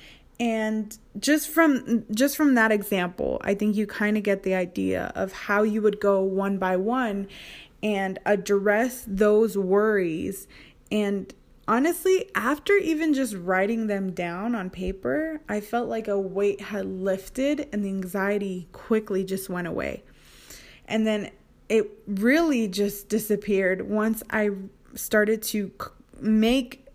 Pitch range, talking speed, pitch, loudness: 195-230 Hz, 140 wpm, 210 Hz, -25 LUFS